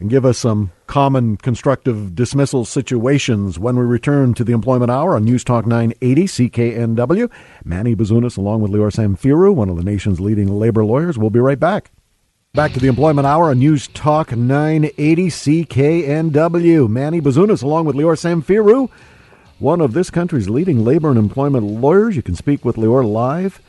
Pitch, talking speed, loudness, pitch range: 130 Hz, 170 wpm, -15 LUFS, 115-155 Hz